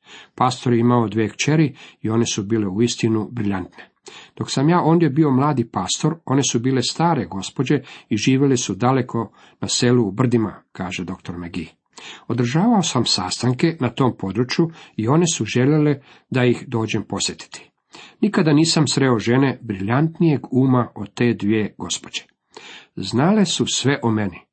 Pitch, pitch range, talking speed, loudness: 125 Hz, 110-145 Hz, 155 wpm, -19 LUFS